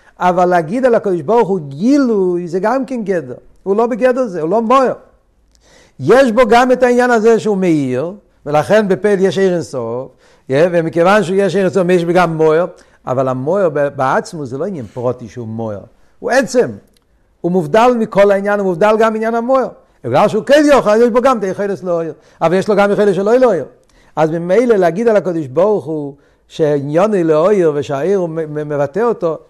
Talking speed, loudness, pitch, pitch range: 185 wpm, -13 LUFS, 190 Hz, 160-220 Hz